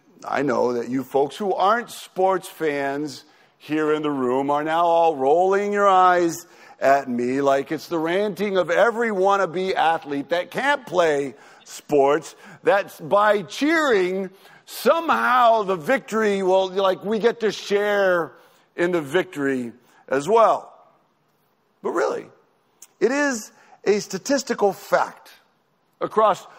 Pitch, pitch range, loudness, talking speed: 185 Hz, 150-210 Hz, -21 LUFS, 130 wpm